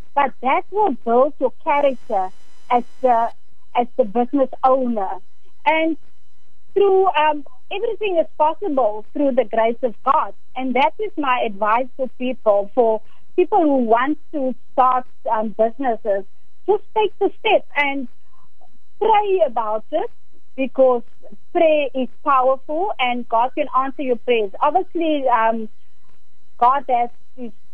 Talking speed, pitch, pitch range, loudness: 130 wpm, 260 Hz, 240-310 Hz, -19 LUFS